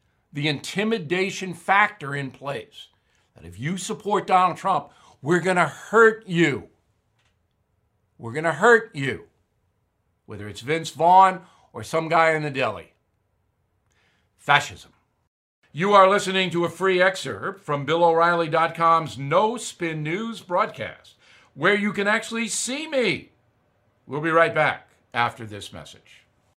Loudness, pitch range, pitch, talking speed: -22 LUFS, 115-190 Hz, 165 Hz, 135 wpm